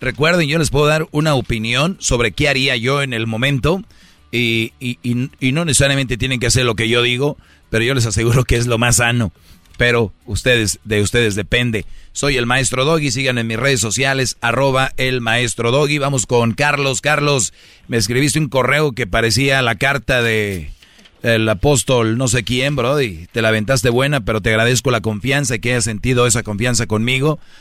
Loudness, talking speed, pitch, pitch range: -16 LUFS, 195 wpm, 125 Hz, 115-135 Hz